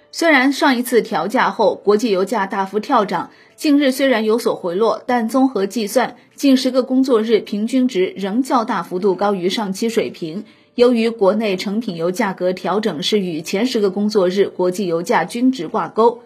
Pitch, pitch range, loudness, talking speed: 220 Hz, 195-250 Hz, -17 LUFS, 280 characters per minute